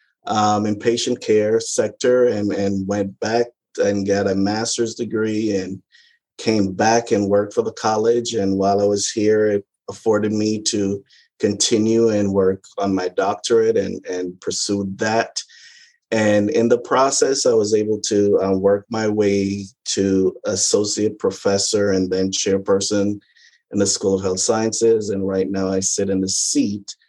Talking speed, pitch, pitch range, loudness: 160 wpm, 105 Hz, 100-115 Hz, -19 LUFS